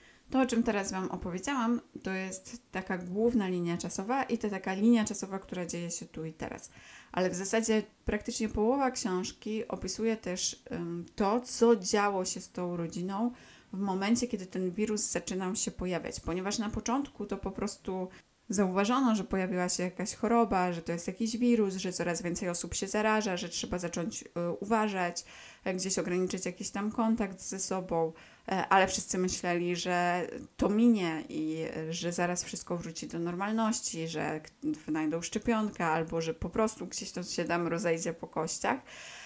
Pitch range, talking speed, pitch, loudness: 175-220 Hz, 165 wpm, 190 Hz, -32 LUFS